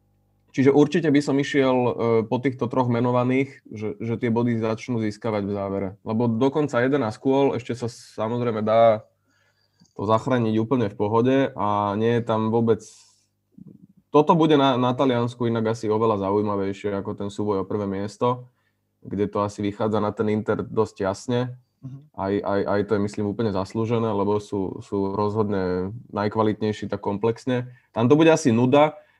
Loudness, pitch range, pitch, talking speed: -23 LUFS, 105-125 Hz, 115 Hz, 160 wpm